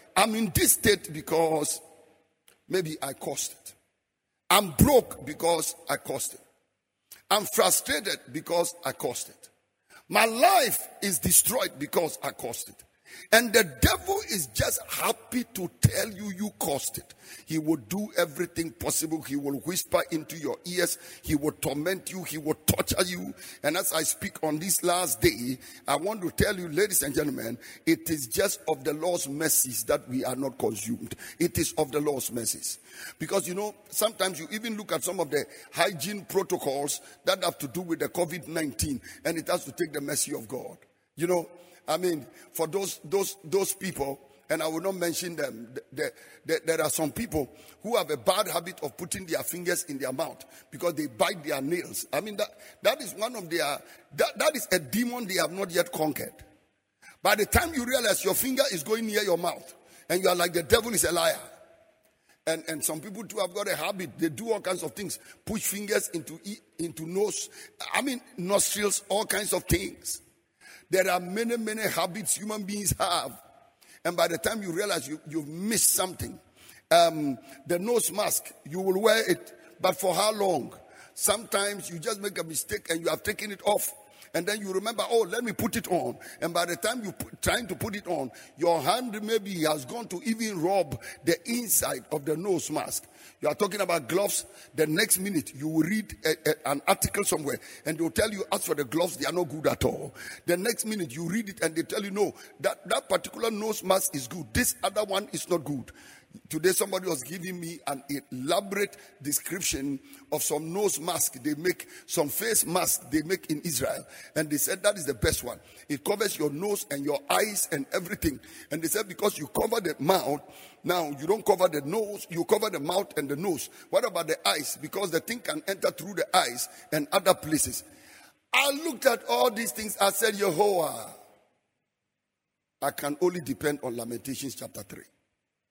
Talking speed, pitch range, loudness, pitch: 200 wpm, 155-205 Hz, -28 LUFS, 175 Hz